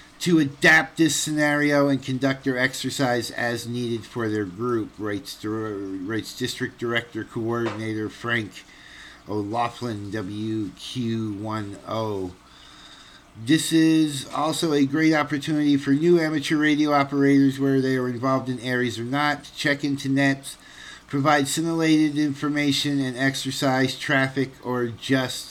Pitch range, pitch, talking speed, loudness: 115-145 Hz, 135 Hz, 120 wpm, -23 LUFS